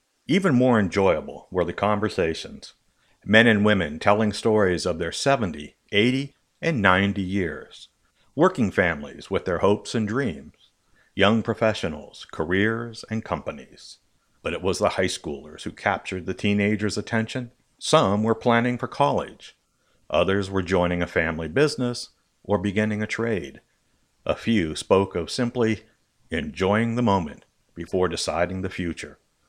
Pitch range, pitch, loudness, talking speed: 95-115 Hz, 105 Hz, -23 LUFS, 140 wpm